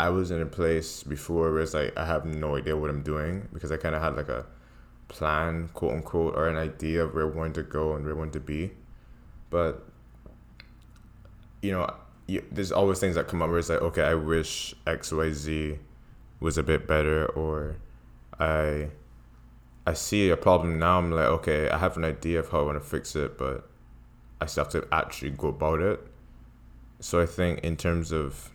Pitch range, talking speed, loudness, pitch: 75-85 Hz, 210 wpm, -28 LUFS, 80 Hz